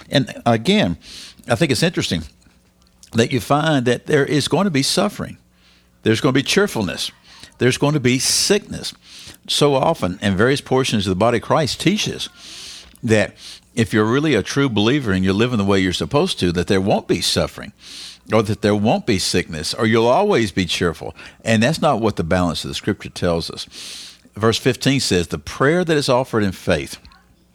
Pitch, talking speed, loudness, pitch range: 115 Hz, 195 wpm, -18 LUFS, 95-135 Hz